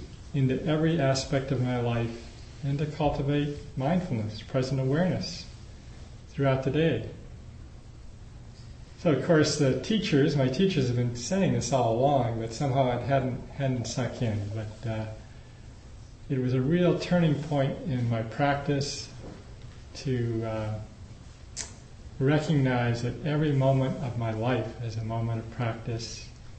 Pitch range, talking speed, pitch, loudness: 115-145 Hz, 135 wpm, 130 Hz, -28 LUFS